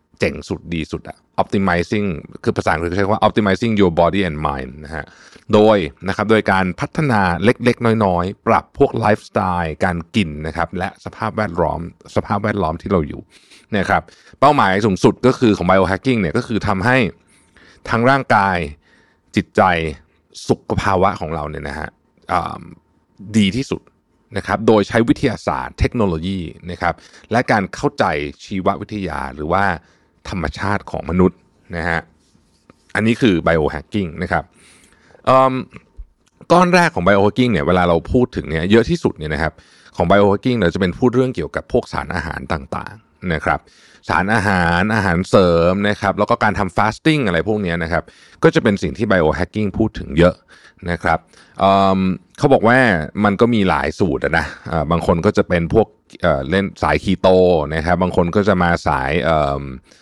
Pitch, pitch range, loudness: 95 Hz, 85-105 Hz, -17 LUFS